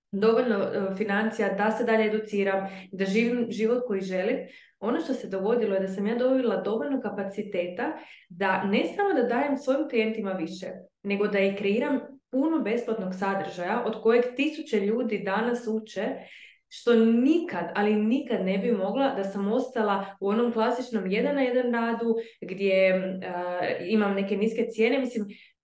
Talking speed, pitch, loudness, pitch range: 155 wpm, 220 Hz, -27 LUFS, 195-240 Hz